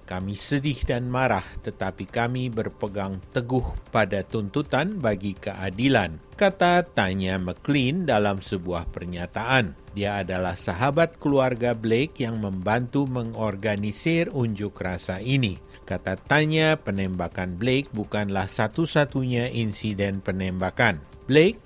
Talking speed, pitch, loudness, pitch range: 105 wpm, 105 Hz, -25 LUFS, 95-130 Hz